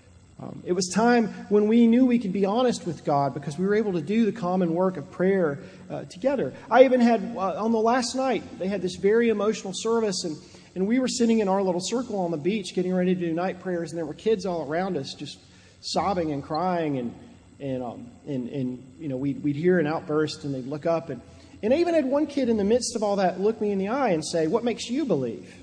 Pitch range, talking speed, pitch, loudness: 165-230 Hz, 260 wpm, 190 Hz, -25 LUFS